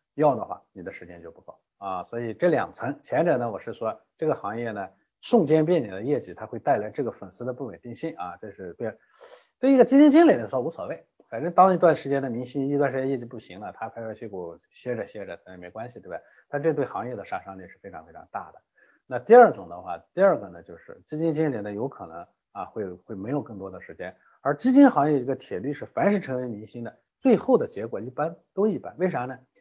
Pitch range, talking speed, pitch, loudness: 115-165 Hz, 355 characters per minute, 135 Hz, -24 LUFS